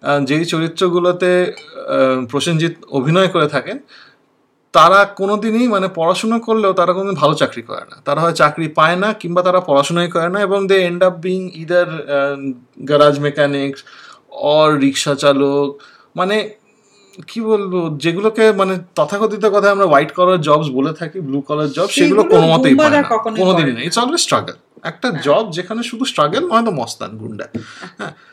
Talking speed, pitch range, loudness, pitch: 145 wpm, 150-200 Hz, -15 LUFS, 180 Hz